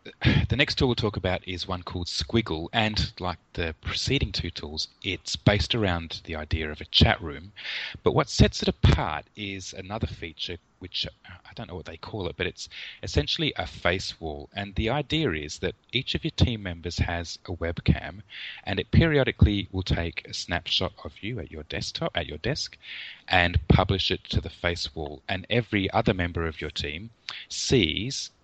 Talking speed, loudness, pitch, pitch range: 190 wpm, -27 LUFS, 90 Hz, 80-105 Hz